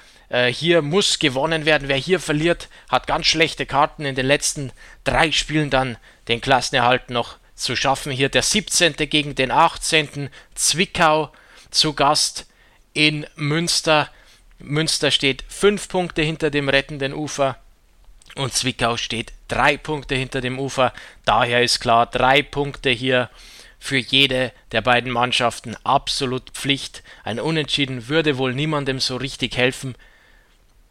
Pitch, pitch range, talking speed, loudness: 135 Hz, 125-155 Hz, 135 wpm, -19 LUFS